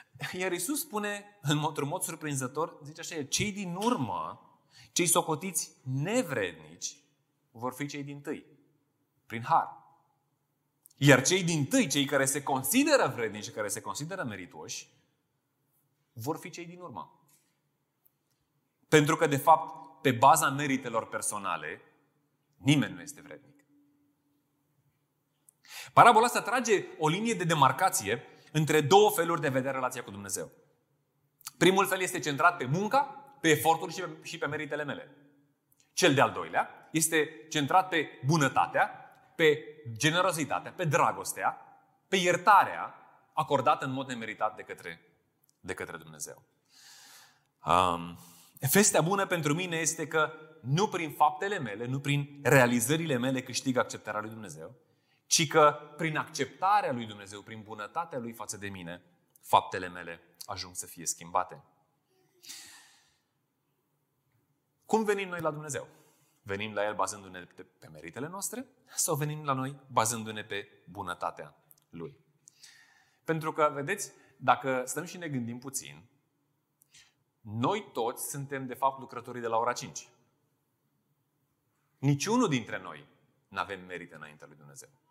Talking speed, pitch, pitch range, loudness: 135 wpm, 145 Hz, 130-160 Hz, -29 LUFS